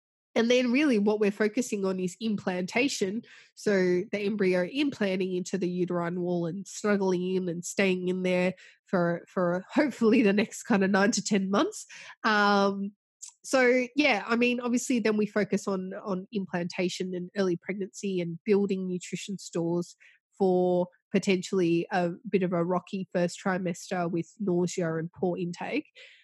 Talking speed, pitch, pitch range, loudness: 160 wpm, 190 Hz, 180-210 Hz, -28 LUFS